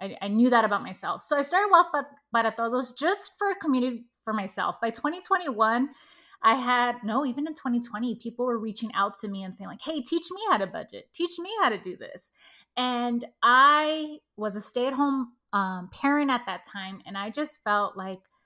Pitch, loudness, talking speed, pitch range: 250 Hz, -26 LUFS, 200 wpm, 215-300 Hz